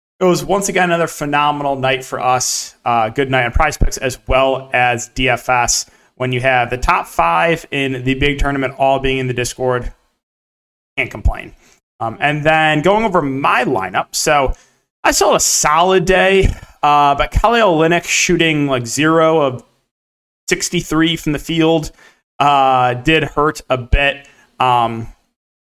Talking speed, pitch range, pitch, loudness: 155 wpm, 125-160 Hz, 140 Hz, -15 LUFS